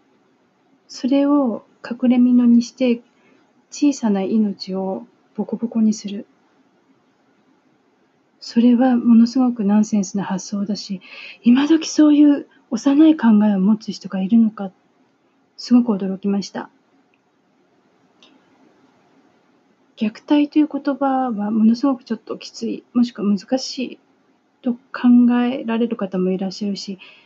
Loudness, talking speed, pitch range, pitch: -18 LUFS, 240 characters per minute, 205-270 Hz, 235 Hz